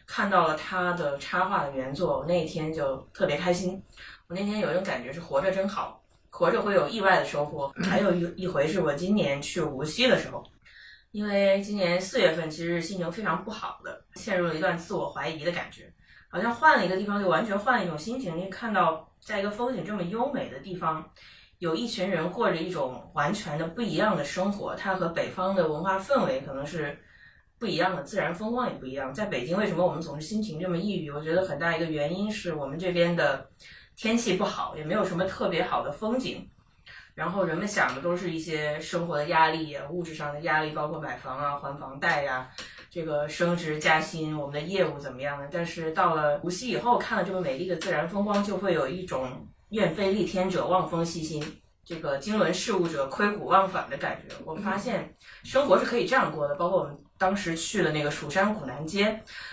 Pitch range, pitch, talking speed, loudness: 155-195 Hz, 175 Hz, 325 characters per minute, -28 LUFS